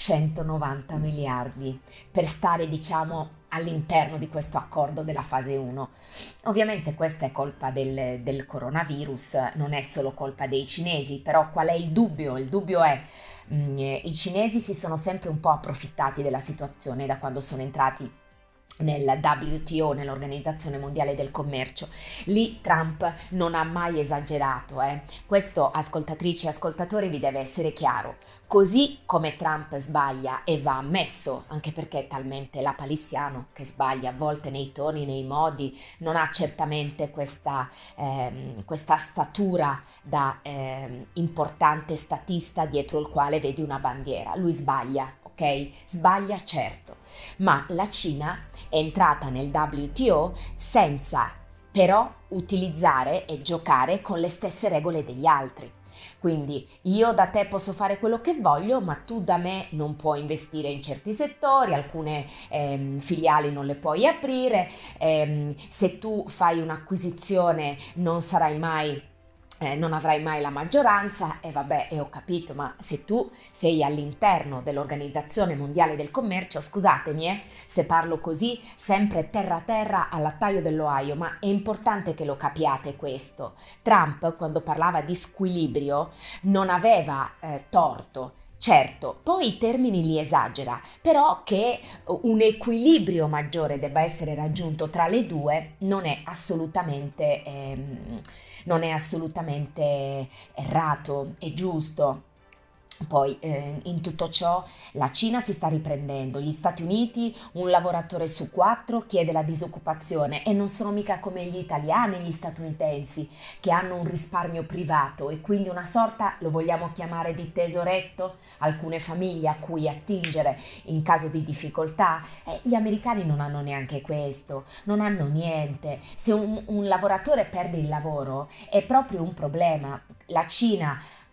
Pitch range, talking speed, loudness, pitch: 145-180 Hz, 145 wpm, -26 LUFS, 155 Hz